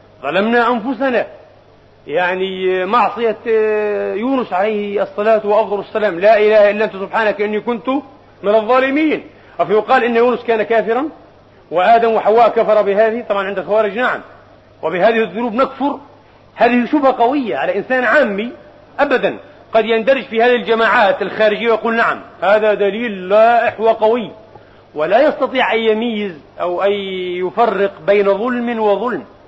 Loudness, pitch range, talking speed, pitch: -15 LUFS, 205-240 Hz, 130 wpm, 220 Hz